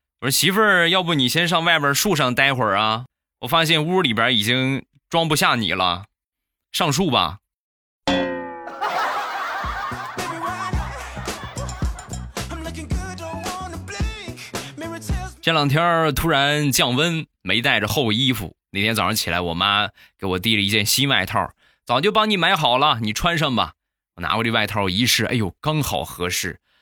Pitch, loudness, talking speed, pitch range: 115 Hz, -20 LUFS, 200 characters per minute, 95-155 Hz